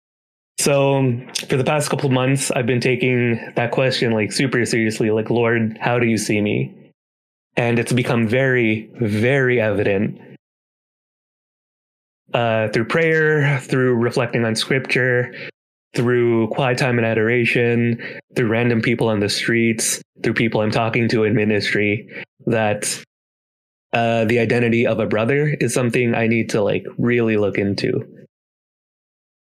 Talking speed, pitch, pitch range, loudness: 140 wpm, 120 Hz, 110-125 Hz, -18 LUFS